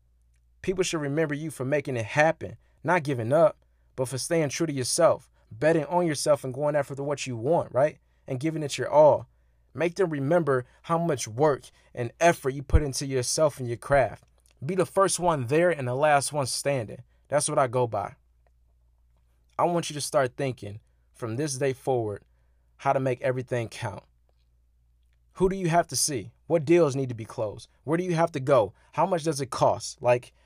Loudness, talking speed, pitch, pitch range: -26 LUFS, 200 wpm, 135 Hz, 110-155 Hz